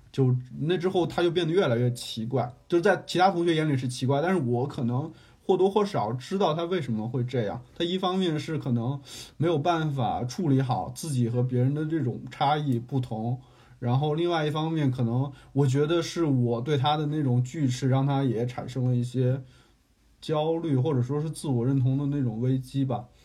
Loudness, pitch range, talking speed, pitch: -27 LUFS, 125-160 Hz, 295 characters per minute, 135 Hz